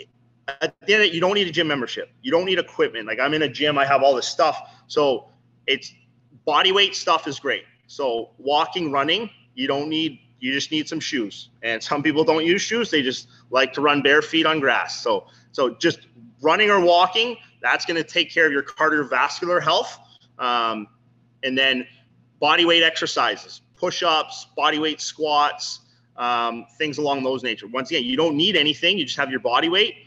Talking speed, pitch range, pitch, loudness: 200 wpm, 125-170 Hz, 150 Hz, -21 LUFS